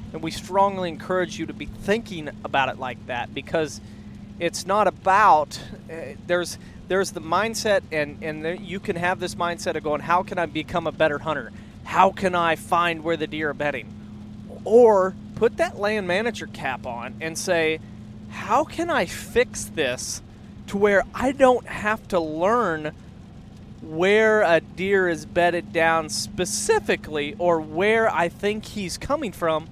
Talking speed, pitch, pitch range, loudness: 165 wpm, 175 Hz, 150-195 Hz, -23 LUFS